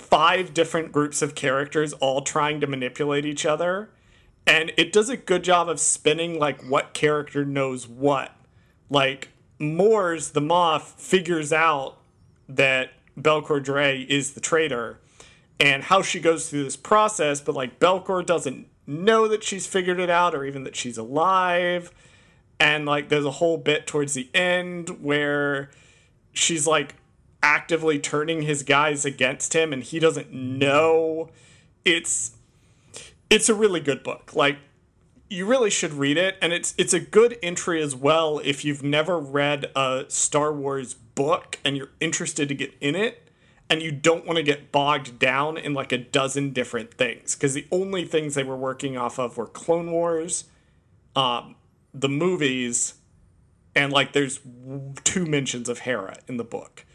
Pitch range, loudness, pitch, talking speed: 135-165 Hz, -23 LUFS, 150 Hz, 160 wpm